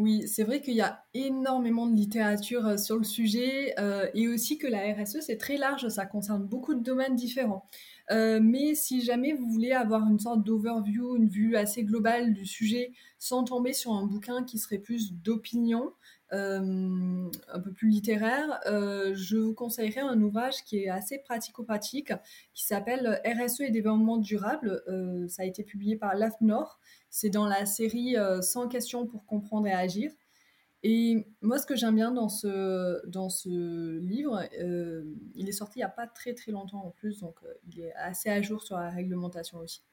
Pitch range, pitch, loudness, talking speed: 200-240 Hz, 220 Hz, -30 LUFS, 190 wpm